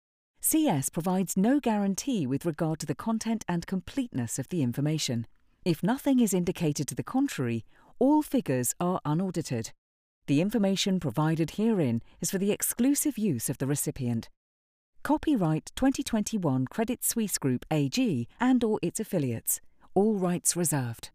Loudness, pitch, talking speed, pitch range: -28 LUFS, 175 Hz, 140 wpm, 135-225 Hz